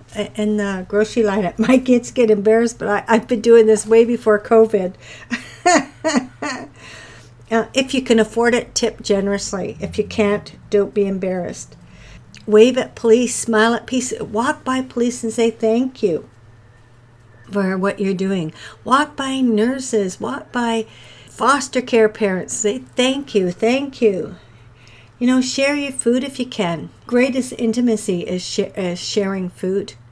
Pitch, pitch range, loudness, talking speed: 220 Hz, 195-245 Hz, -18 LUFS, 150 wpm